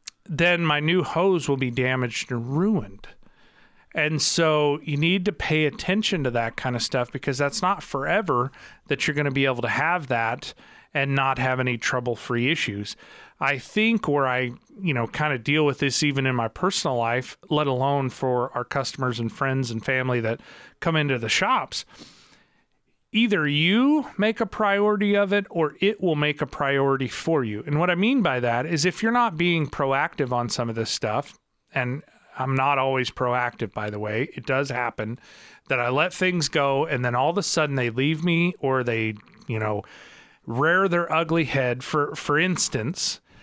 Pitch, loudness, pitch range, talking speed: 140 Hz, -24 LUFS, 125-170 Hz, 190 wpm